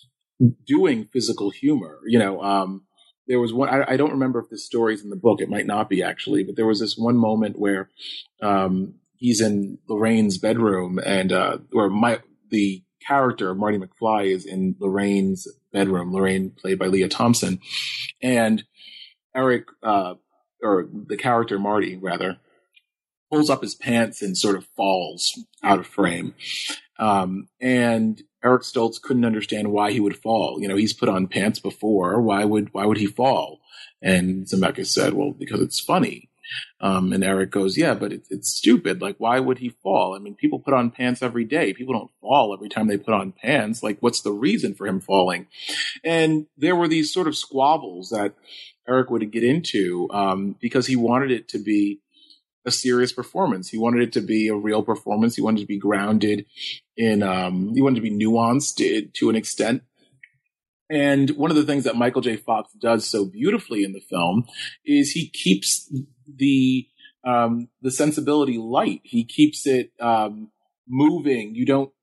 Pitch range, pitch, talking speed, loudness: 100-130 Hz, 115 Hz, 180 wpm, -22 LUFS